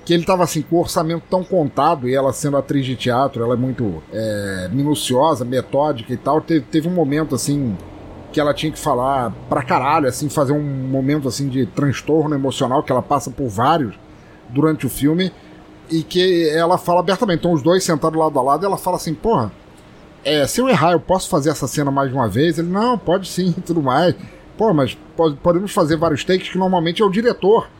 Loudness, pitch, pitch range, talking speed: -18 LUFS, 155 Hz, 135-175 Hz, 215 wpm